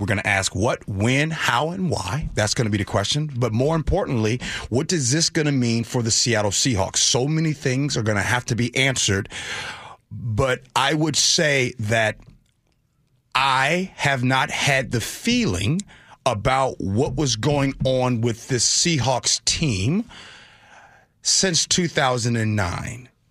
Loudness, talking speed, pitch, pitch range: -21 LUFS, 155 wpm, 130 Hz, 115-150 Hz